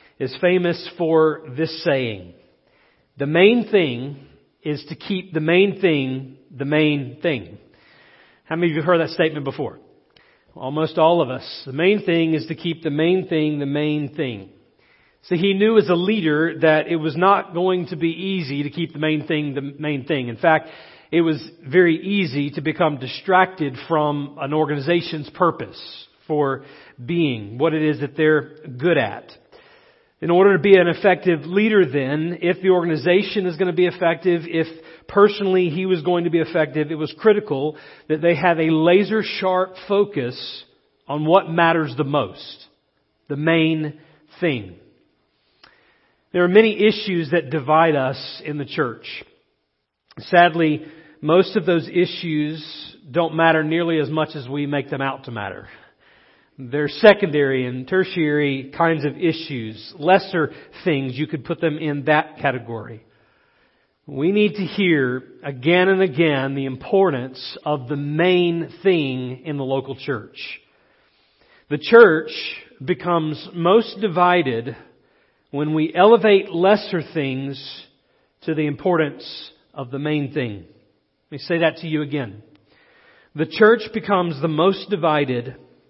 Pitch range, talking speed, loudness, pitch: 145-180 Hz, 150 wpm, -19 LUFS, 160 Hz